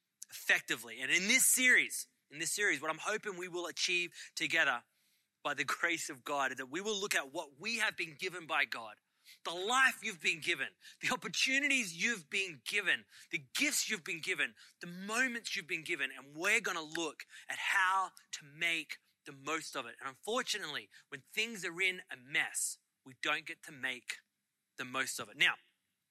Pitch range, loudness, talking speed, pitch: 160-215 Hz, -34 LUFS, 195 wpm, 180 Hz